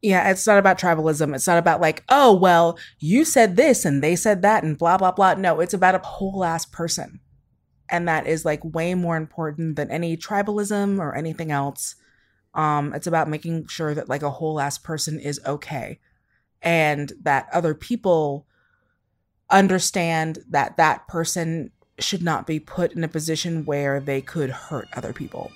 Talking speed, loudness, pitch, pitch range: 180 wpm, -21 LUFS, 165 Hz, 155-185 Hz